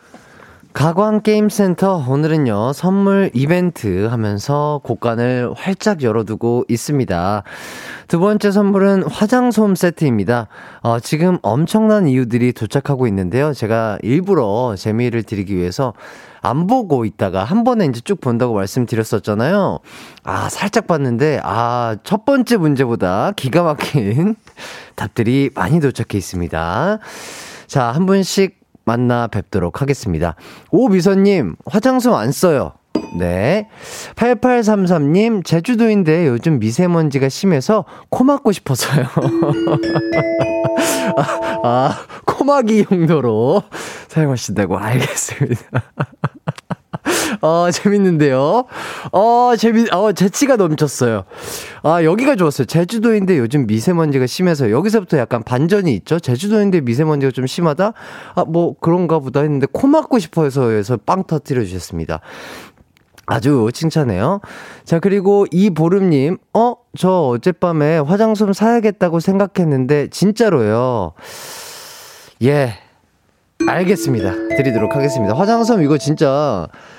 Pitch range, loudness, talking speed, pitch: 120-200 Hz, -16 LUFS, 275 characters per minute, 155 Hz